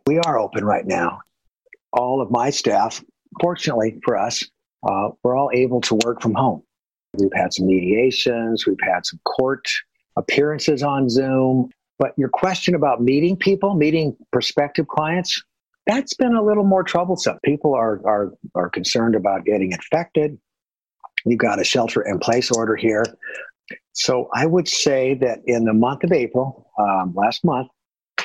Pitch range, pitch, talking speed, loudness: 115-170 Hz, 135 Hz, 160 wpm, -20 LUFS